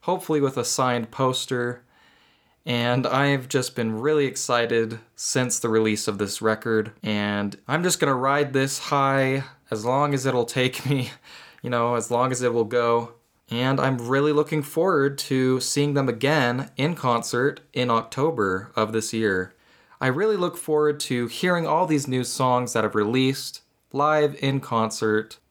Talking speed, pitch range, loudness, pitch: 165 wpm, 115-140 Hz, -23 LUFS, 125 Hz